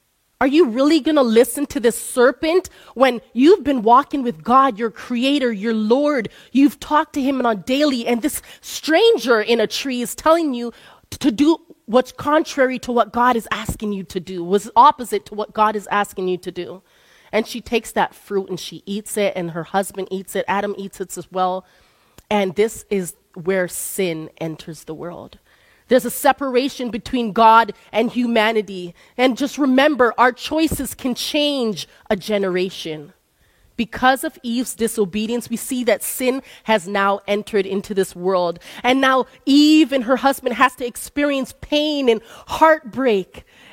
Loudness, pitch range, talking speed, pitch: -18 LUFS, 200-265 Hz, 170 wpm, 235 Hz